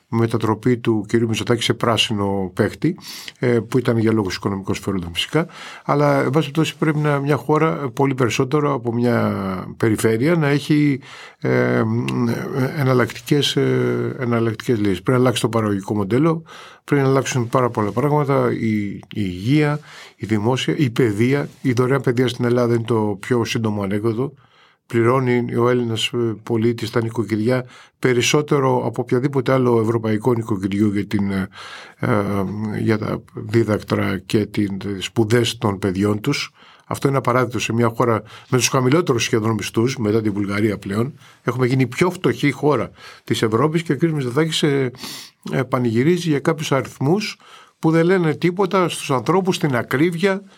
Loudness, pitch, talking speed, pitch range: -19 LUFS, 120 Hz, 145 wpm, 110-140 Hz